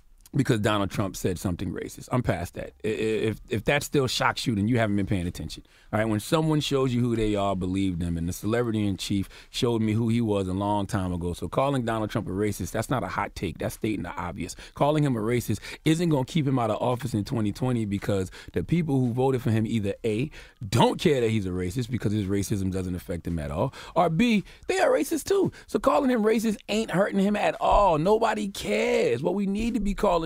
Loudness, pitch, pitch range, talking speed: -26 LUFS, 115 Hz, 100-150 Hz, 240 wpm